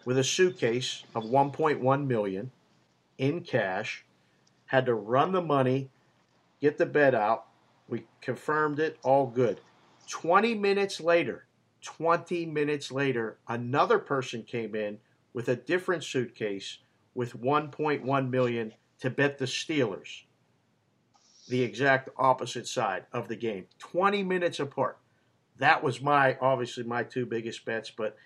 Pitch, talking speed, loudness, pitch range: 130 Hz, 130 wpm, -28 LUFS, 120-150 Hz